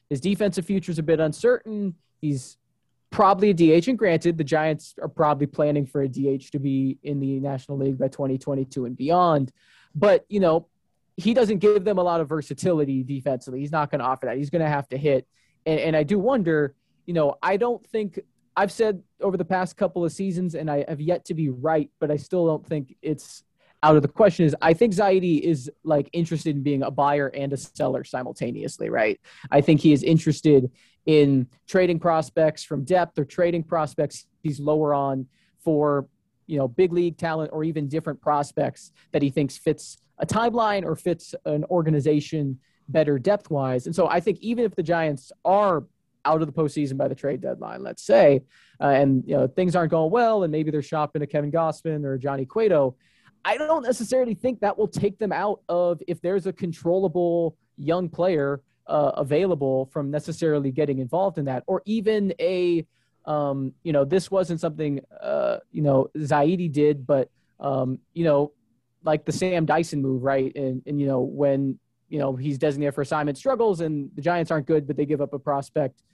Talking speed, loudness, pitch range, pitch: 200 wpm, -24 LUFS, 140-180 Hz, 155 Hz